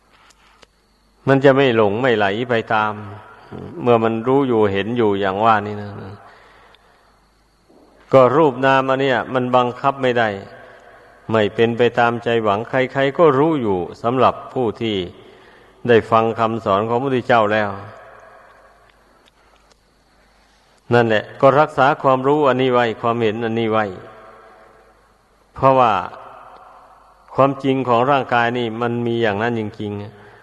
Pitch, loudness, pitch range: 115 Hz, -17 LUFS, 110-130 Hz